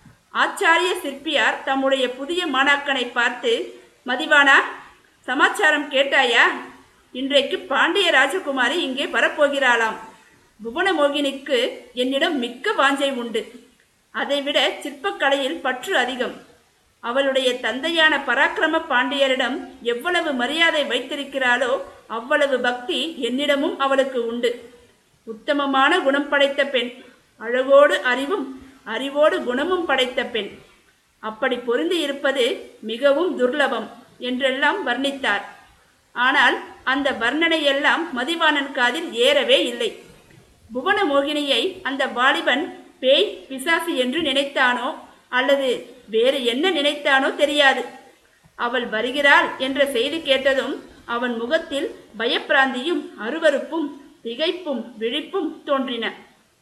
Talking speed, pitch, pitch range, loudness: 85 wpm, 275 Hz, 250-310 Hz, -20 LUFS